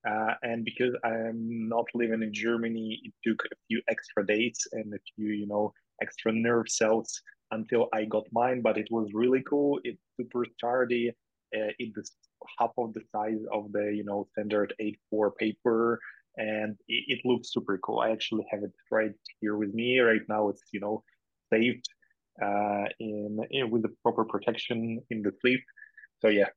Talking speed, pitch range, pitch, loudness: 180 wpm, 105-120 Hz, 110 Hz, -30 LUFS